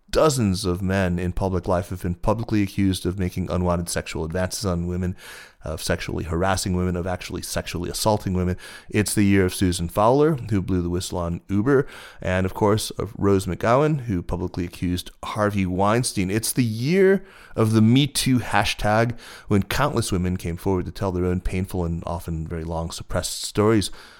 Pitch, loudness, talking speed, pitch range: 95 Hz, -23 LUFS, 180 wpm, 90-110 Hz